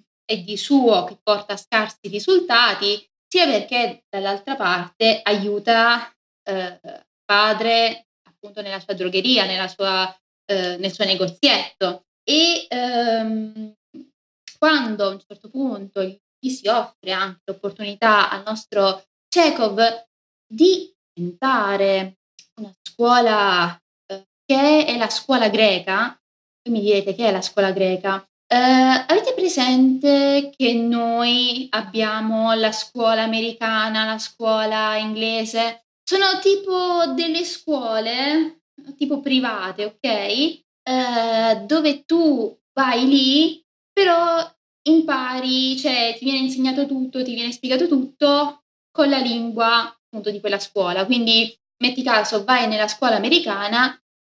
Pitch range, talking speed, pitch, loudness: 205-270 Hz, 115 wpm, 230 Hz, -19 LUFS